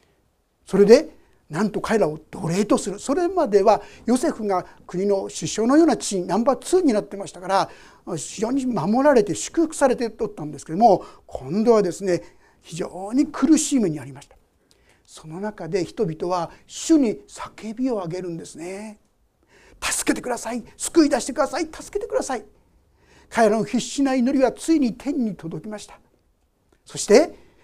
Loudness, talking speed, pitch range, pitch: -21 LUFS, 330 characters per minute, 185-275 Hz, 220 Hz